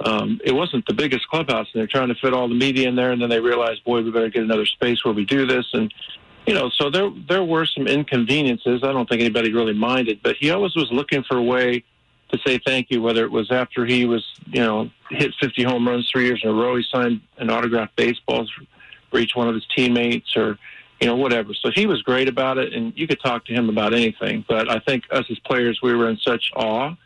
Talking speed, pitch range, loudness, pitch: 255 wpm, 115-130 Hz, -20 LUFS, 125 Hz